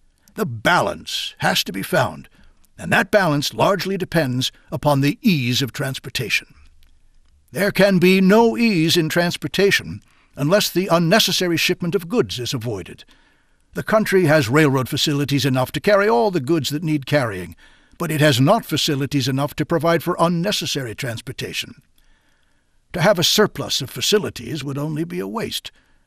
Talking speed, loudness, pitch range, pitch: 155 wpm, -19 LUFS, 135-185 Hz, 155 Hz